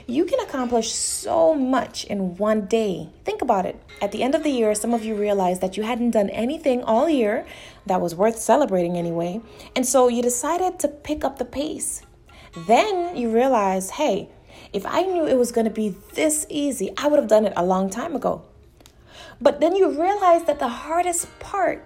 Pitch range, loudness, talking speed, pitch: 215-310 Hz, -22 LUFS, 200 wpm, 245 Hz